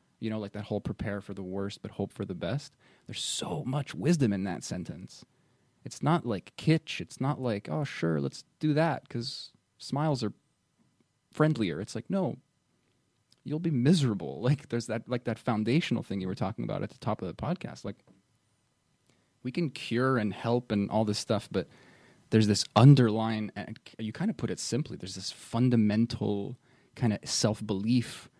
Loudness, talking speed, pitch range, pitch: -30 LUFS, 185 wpm, 105-130 Hz, 115 Hz